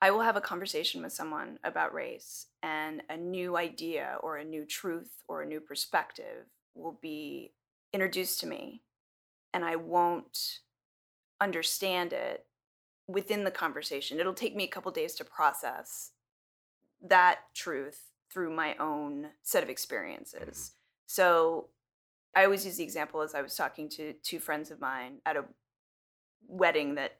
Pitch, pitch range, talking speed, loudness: 175 Hz, 155-200 Hz, 155 wpm, -32 LUFS